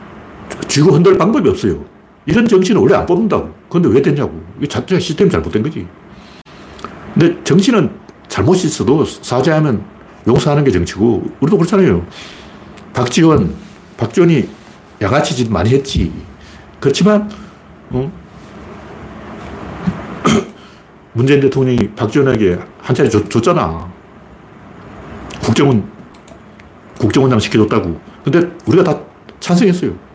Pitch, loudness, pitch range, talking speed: 130 Hz, -14 LUFS, 105-170 Hz, 270 characters per minute